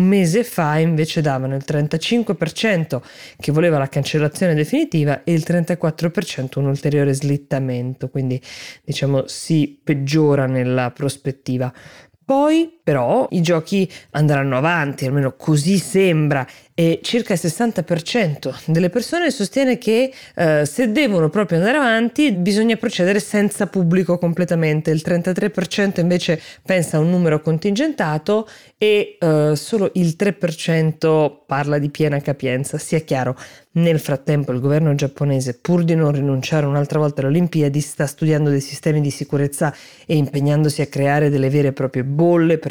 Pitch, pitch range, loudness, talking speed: 155 Hz, 140-180 Hz, -18 LUFS, 140 wpm